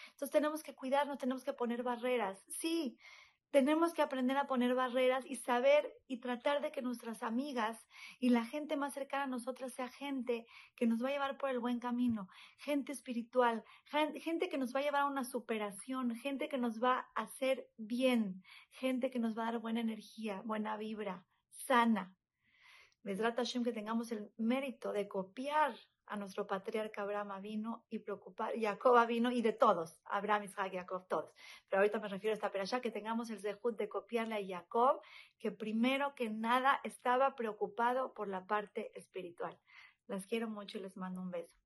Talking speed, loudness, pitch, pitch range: 185 wpm, -37 LUFS, 240 Hz, 215-265 Hz